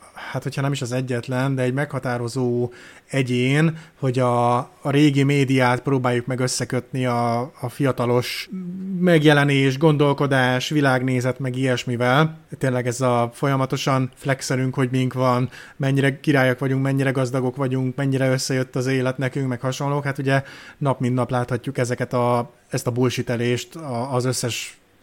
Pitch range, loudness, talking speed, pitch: 125-140 Hz, -21 LUFS, 145 wpm, 130 Hz